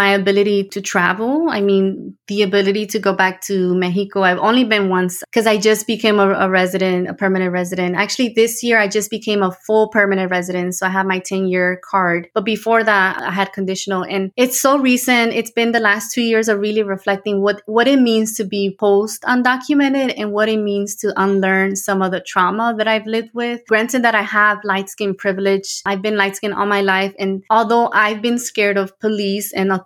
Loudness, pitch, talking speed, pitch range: -16 LUFS, 205 Hz, 210 wpm, 195-220 Hz